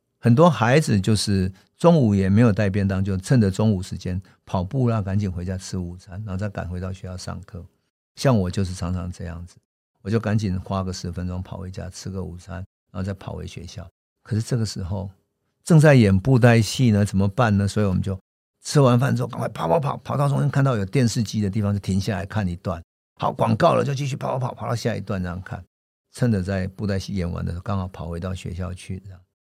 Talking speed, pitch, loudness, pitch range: 335 characters per minute, 100 Hz, -22 LUFS, 95-115 Hz